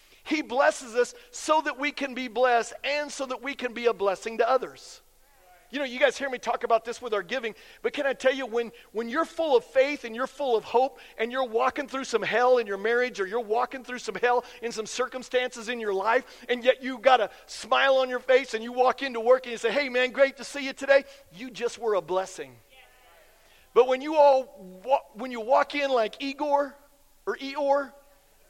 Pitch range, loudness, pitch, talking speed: 235-275 Hz, -26 LUFS, 255 Hz, 230 wpm